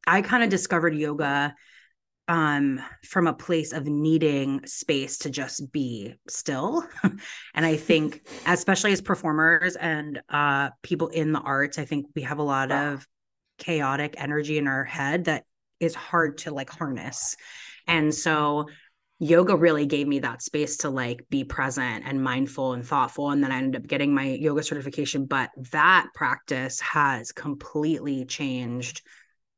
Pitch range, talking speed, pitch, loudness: 140-160 Hz, 155 wpm, 150 Hz, -25 LUFS